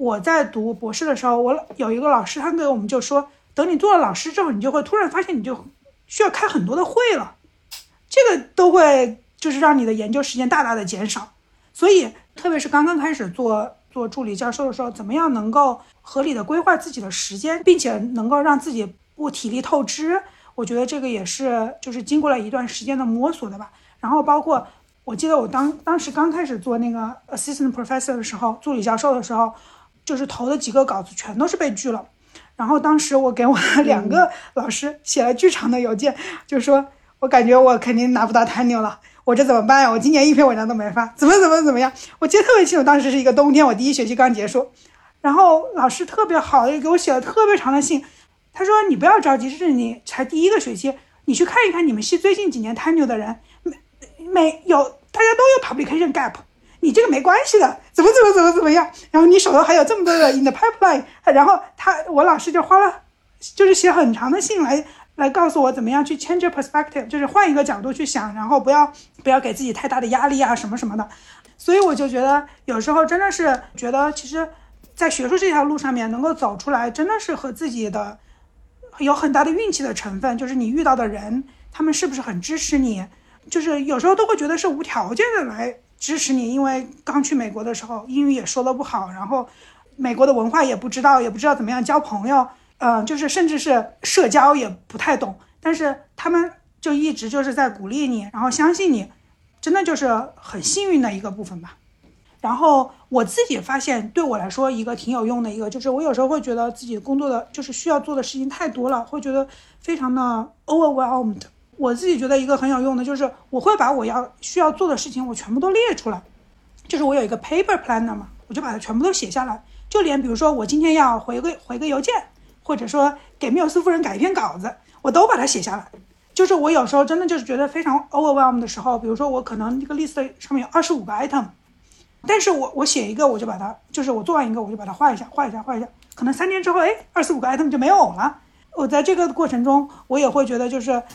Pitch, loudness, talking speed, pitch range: 275 Hz, -18 LUFS, 370 characters per minute, 245-320 Hz